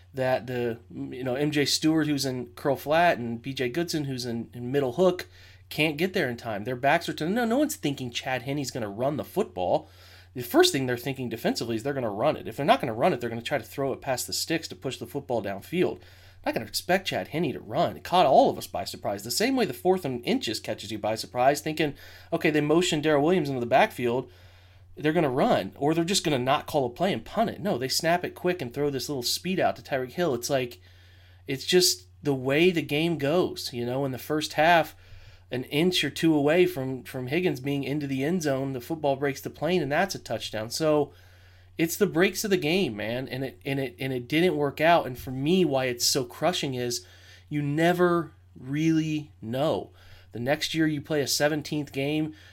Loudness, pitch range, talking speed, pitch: -26 LUFS, 120-155 Hz, 235 wpm, 135 Hz